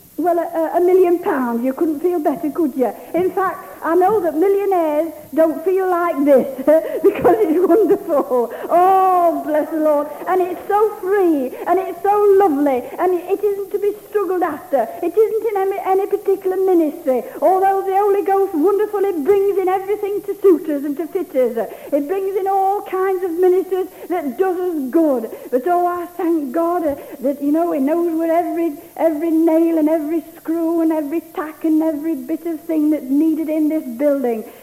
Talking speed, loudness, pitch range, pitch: 185 wpm, -17 LUFS, 310-380 Hz, 340 Hz